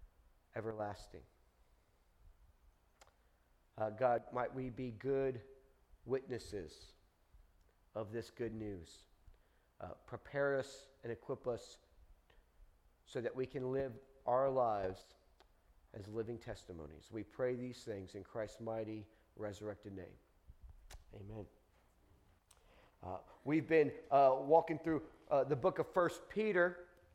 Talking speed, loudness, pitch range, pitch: 110 wpm, -39 LUFS, 90-135 Hz, 110 Hz